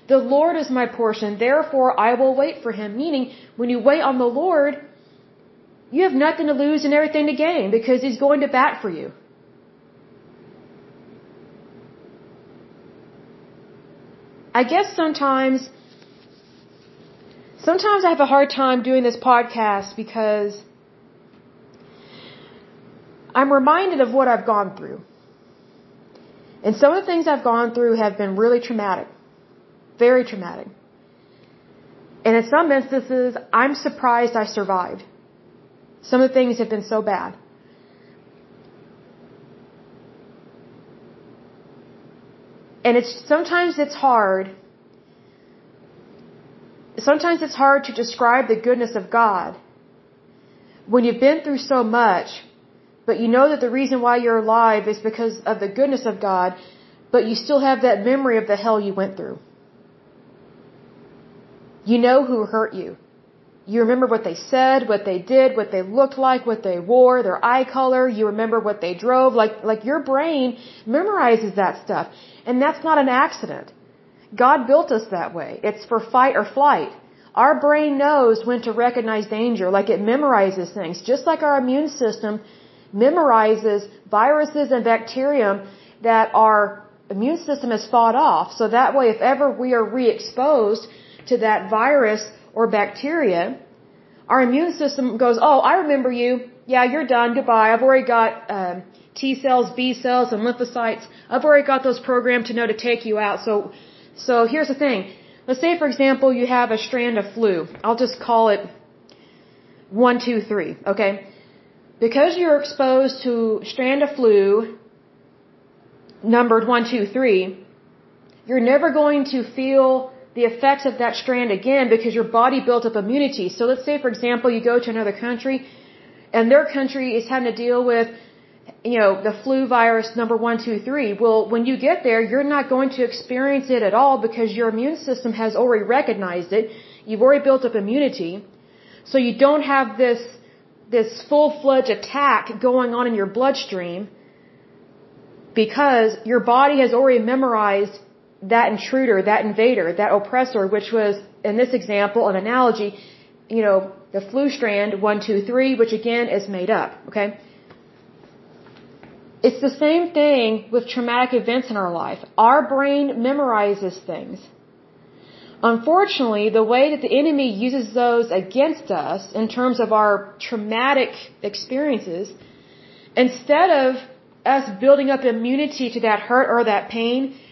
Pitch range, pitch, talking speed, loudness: 220-265 Hz, 240 Hz, 150 wpm, -19 LUFS